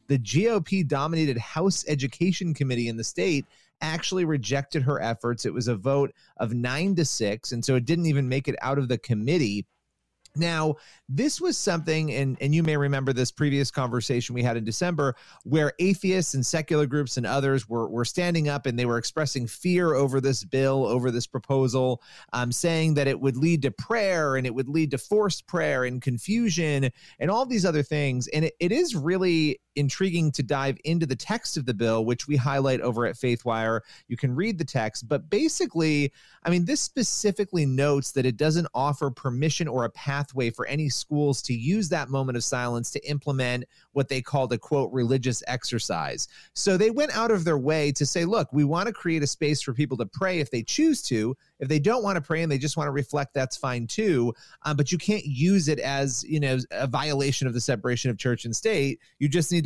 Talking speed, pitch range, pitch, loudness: 210 wpm, 130-165 Hz, 140 Hz, -26 LUFS